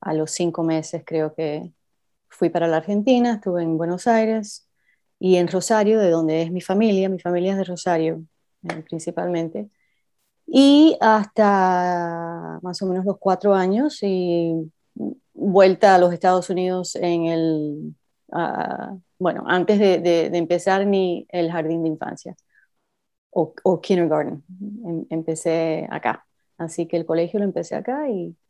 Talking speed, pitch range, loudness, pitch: 145 wpm, 165-195 Hz, -20 LUFS, 175 Hz